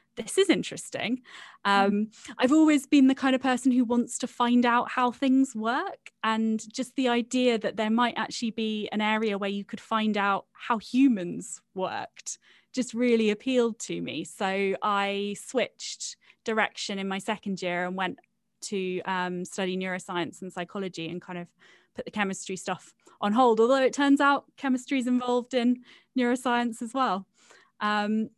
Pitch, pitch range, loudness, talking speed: 220 Hz, 200-250 Hz, -27 LUFS, 170 wpm